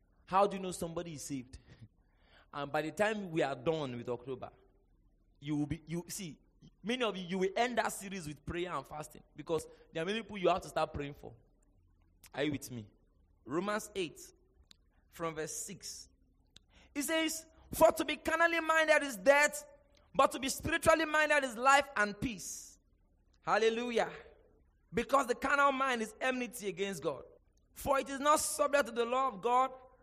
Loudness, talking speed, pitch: -33 LUFS, 180 wpm, 195 Hz